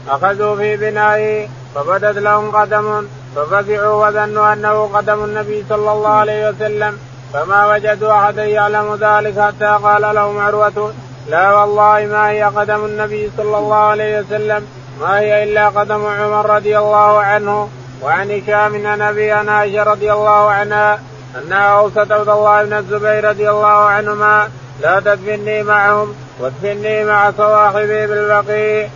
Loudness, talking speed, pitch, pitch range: -13 LUFS, 135 wpm, 210 Hz, 205-210 Hz